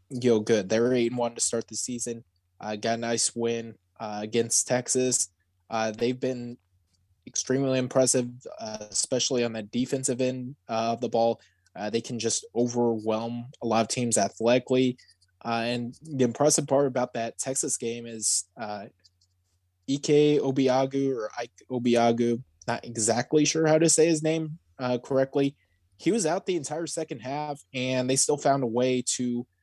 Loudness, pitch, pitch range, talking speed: -26 LUFS, 120 Hz, 110-130 Hz, 170 wpm